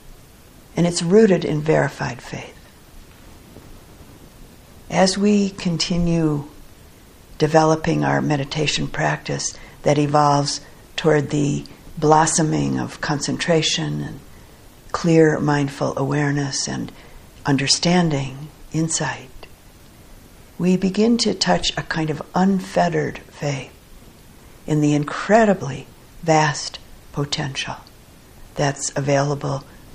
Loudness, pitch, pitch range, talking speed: -20 LUFS, 150 Hz, 140-165 Hz, 85 wpm